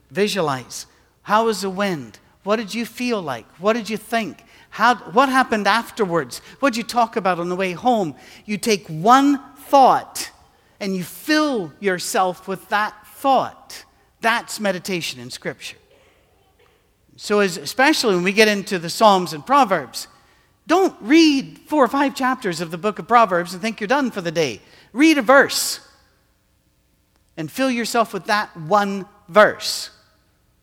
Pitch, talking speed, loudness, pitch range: 210 Hz, 160 wpm, -19 LUFS, 185-250 Hz